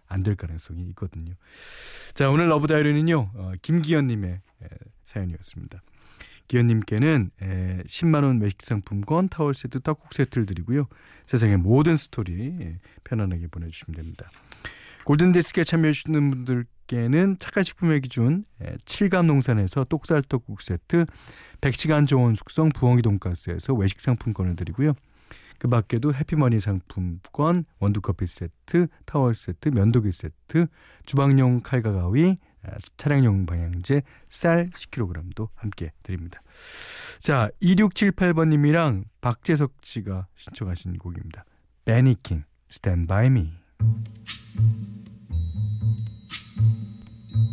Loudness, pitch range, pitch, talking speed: -23 LUFS, 95-145 Hz, 115 Hz, 275 characters per minute